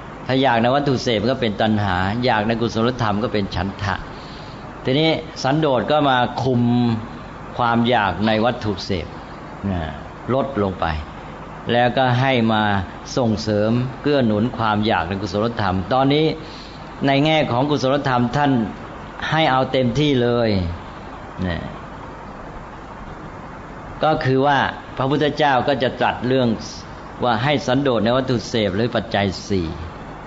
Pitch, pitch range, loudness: 120 Hz, 100-130 Hz, -19 LUFS